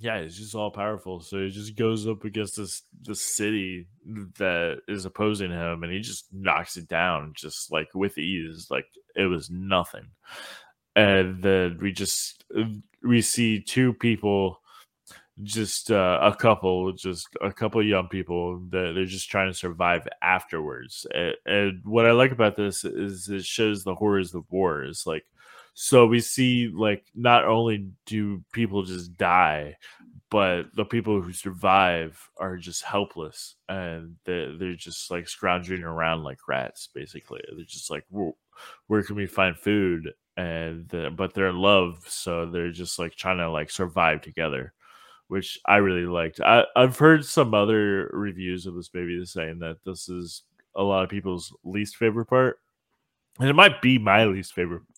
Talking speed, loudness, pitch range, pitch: 170 wpm, -24 LUFS, 90-105 Hz, 95 Hz